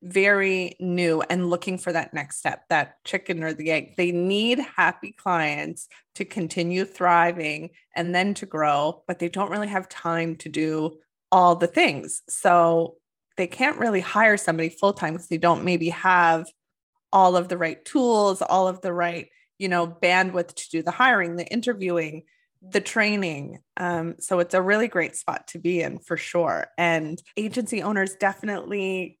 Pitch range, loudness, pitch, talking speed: 170-195 Hz, -23 LUFS, 180 Hz, 170 wpm